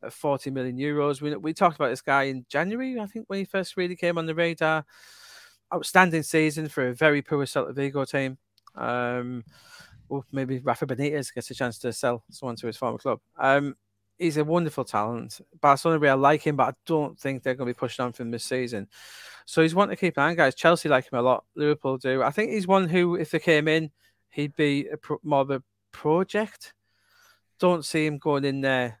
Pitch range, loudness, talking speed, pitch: 130-165 Hz, -25 LUFS, 225 wpm, 145 Hz